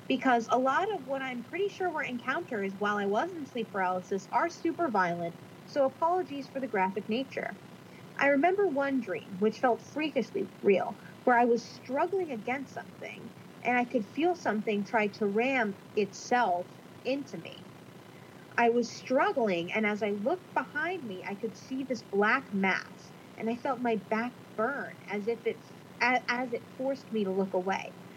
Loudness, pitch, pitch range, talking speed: -31 LUFS, 235 Hz, 205-270 Hz, 175 wpm